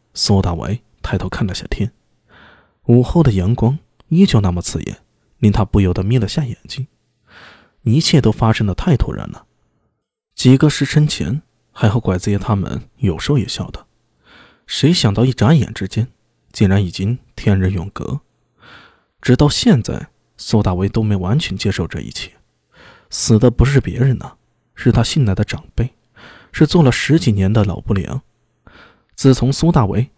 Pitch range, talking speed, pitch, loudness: 100-130 Hz, 235 characters per minute, 110 Hz, -16 LUFS